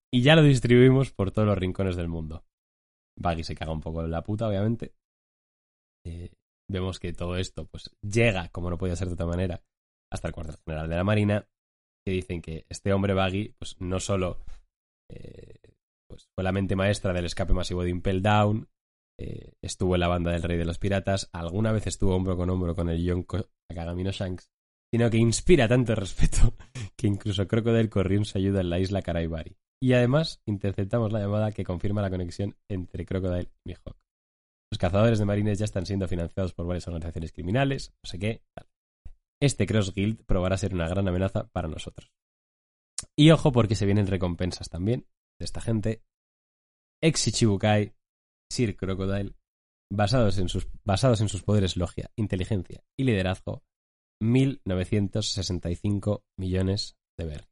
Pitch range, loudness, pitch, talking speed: 85-105 Hz, -27 LUFS, 95 Hz, 170 wpm